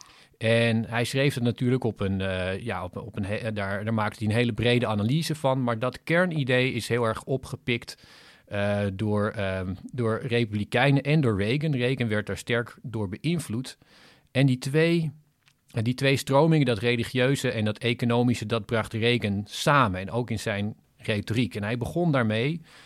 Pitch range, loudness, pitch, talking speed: 110-130 Hz, -26 LUFS, 120 Hz, 175 wpm